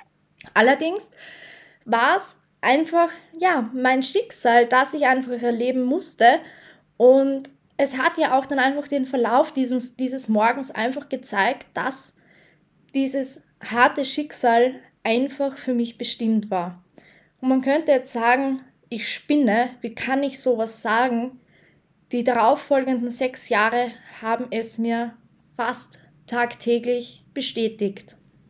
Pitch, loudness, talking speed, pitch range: 255 Hz, -22 LUFS, 120 wpm, 235-275 Hz